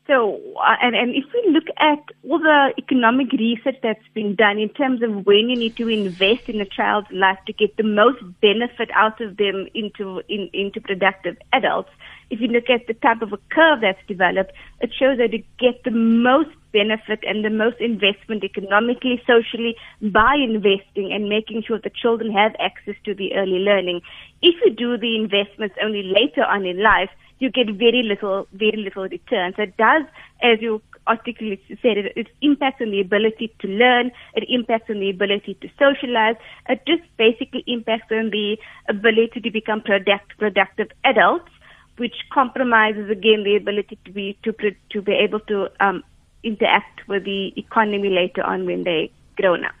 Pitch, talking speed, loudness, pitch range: 220 Hz, 180 wpm, -19 LUFS, 205-240 Hz